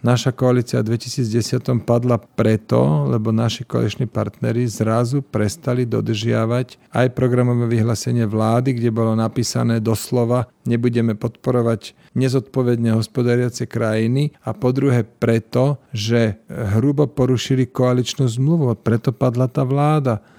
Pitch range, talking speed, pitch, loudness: 115-125 Hz, 115 wpm, 120 Hz, -19 LUFS